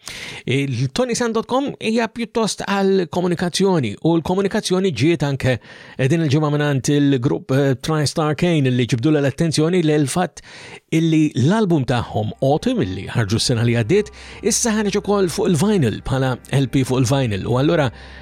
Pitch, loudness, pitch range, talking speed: 155 Hz, -19 LUFS, 130-190 Hz, 135 wpm